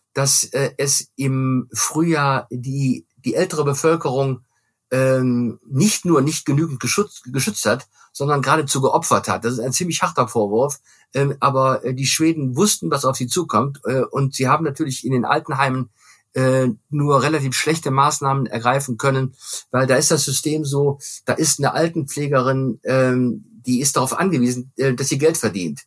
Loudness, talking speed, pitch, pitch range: -19 LUFS, 150 wpm, 135 Hz, 130-150 Hz